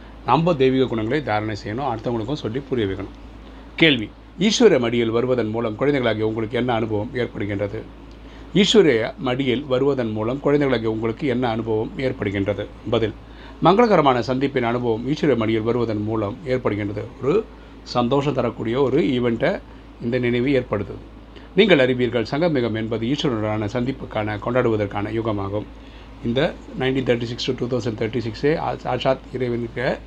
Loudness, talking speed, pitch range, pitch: -21 LUFS, 130 wpm, 110-130 Hz, 120 Hz